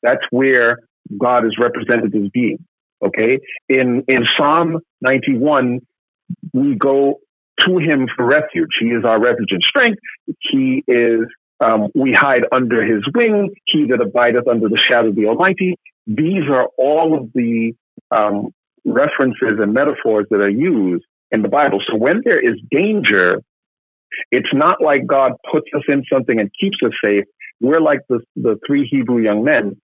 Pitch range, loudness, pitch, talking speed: 115-165 Hz, -15 LUFS, 125 Hz, 165 wpm